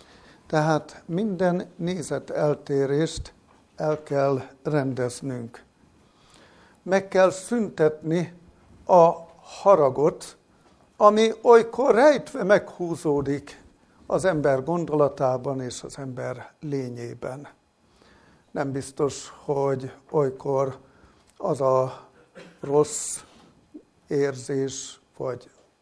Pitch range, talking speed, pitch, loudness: 135-175 Hz, 75 wpm, 145 Hz, -24 LUFS